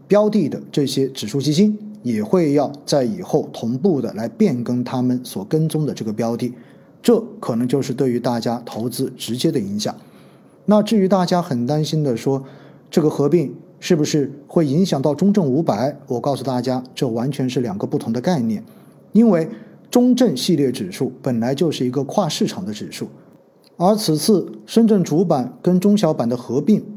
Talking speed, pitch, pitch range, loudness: 270 characters per minute, 155 Hz, 130-200 Hz, -19 LUFS